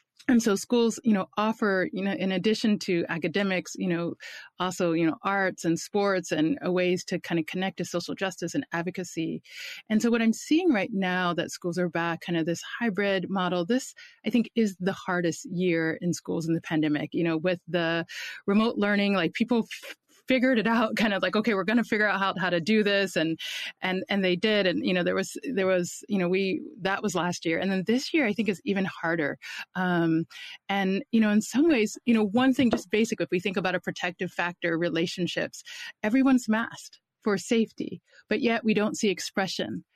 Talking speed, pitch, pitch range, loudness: 215 wpm, 195 Hz, 175-220 Hz, -27 LUFS